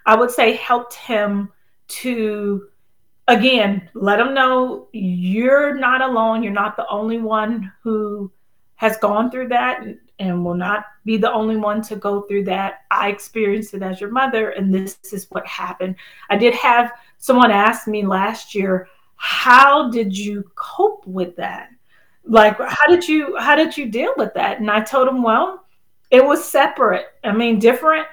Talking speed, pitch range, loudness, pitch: 175 wpm, 200-250 Hz, -17 LUFS, 220 Hz